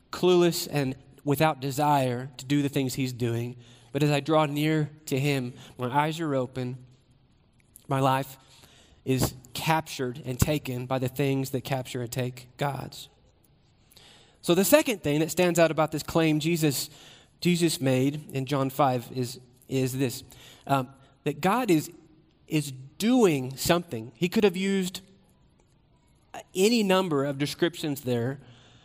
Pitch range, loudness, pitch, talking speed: 130-155 Hz, -27 LUFS, 140 Hz, 145 wpm